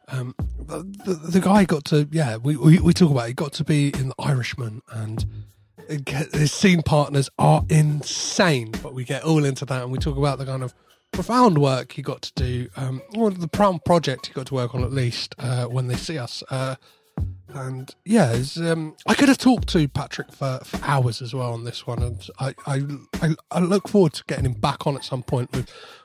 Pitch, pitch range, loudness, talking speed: 140 Hz, 125-165 Hz, -22 LUFS, 230 wpm